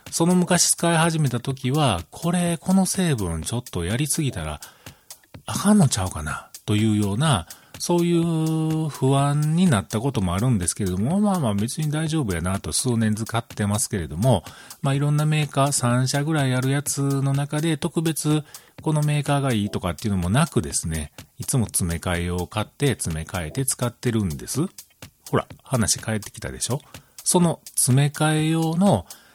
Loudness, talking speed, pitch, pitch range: -22 LUFS, 355 characters per minute, 135 Hz, 105-155 Hz